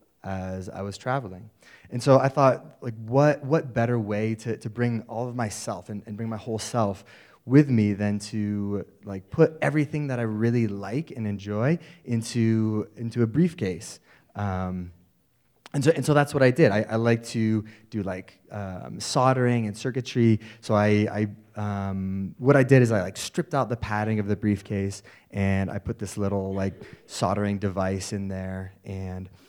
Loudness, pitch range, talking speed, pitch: -25 LUFS, 100-120 Hz, 180 wpm, 110 Hz